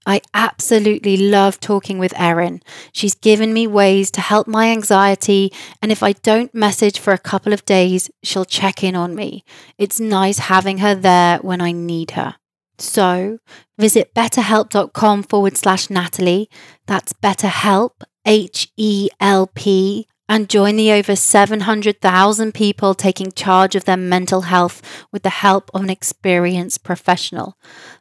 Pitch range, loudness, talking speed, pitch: 185-210 Hz, -15 LUFS, 150 wpm, 195 Hz